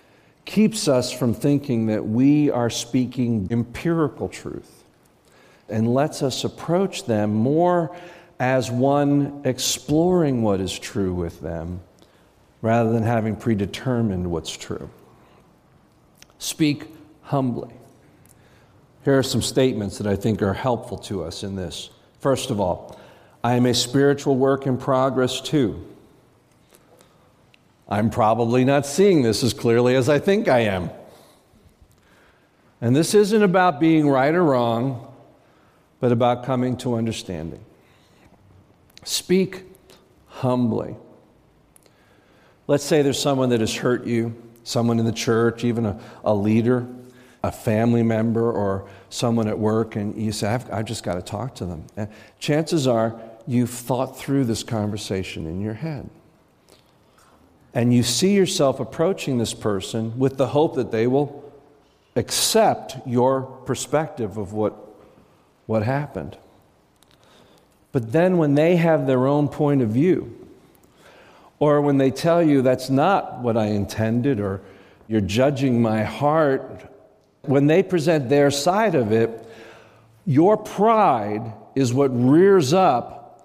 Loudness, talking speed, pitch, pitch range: -21 LUFS, 135 wpm, 125 Hz, 110-140 Hz